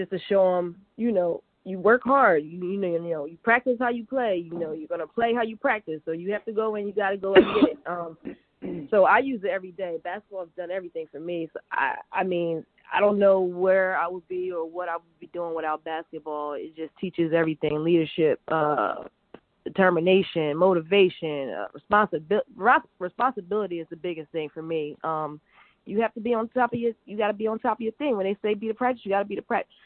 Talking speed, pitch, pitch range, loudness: 235 wpm, 185 Hz, 165-210 Hz, -25 LUFS